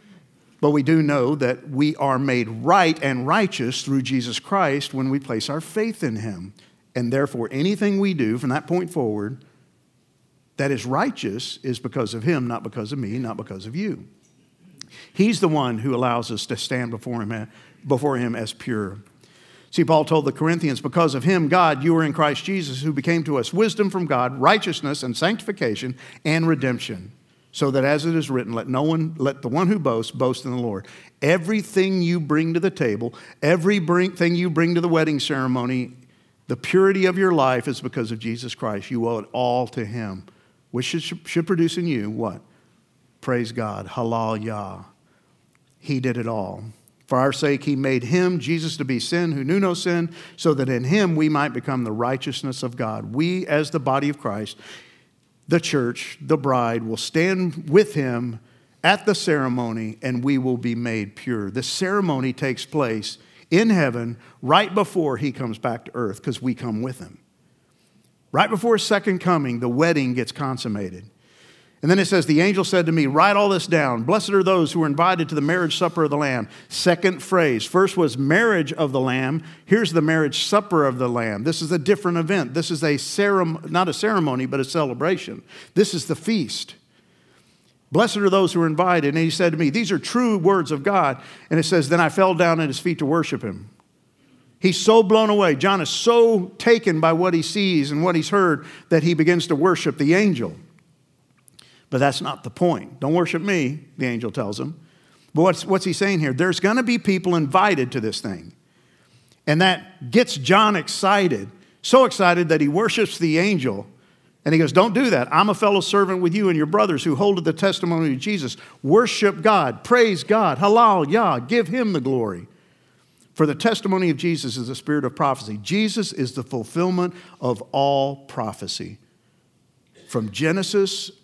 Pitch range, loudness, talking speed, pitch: 125-180 Hz, -21 LUFS, 195 wpm, 155 Hz